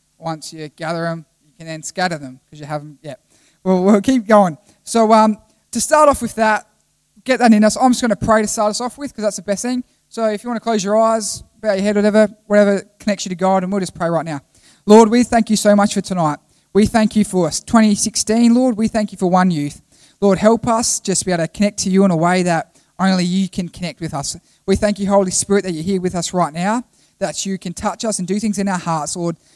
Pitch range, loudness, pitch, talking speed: 170-215 Hz, -16 LUFS, 200 Hz, 270 wpm